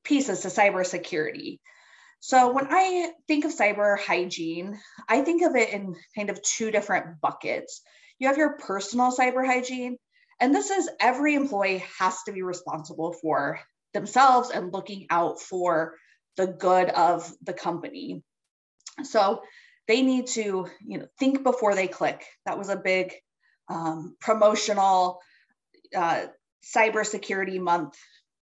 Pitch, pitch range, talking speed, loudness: 210 Hz, 185-260 Hz, 135 wpm, -25 LUFS